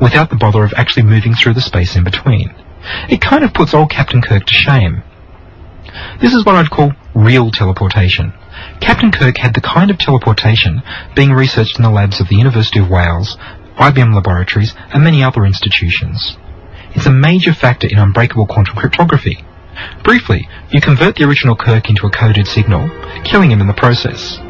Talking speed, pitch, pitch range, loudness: 180 wpm, 110 Hz, 95-130 Hz, -10 LUFS